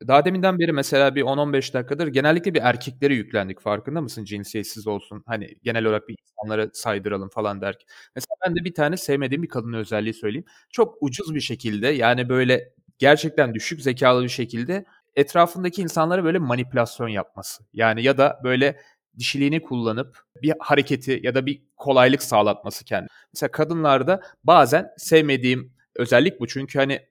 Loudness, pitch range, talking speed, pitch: -22 LUFS, 115-155 Hz, 155 wpm, 135 Hz